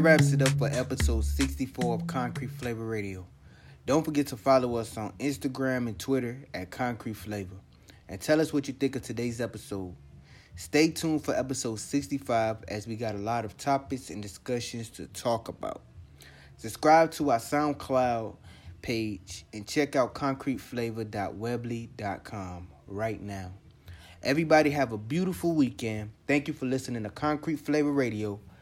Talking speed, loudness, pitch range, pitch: 150 wpm, -29 LUFS, 100-140 Hz, 115 Hz